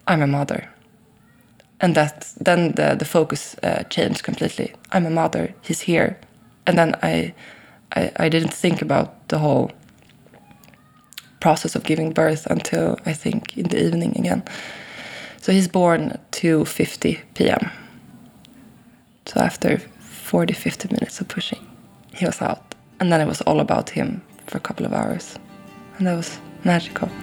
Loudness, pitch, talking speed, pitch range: -21 LUFS, 165 Hz, 150 wpm, 150-175 Hz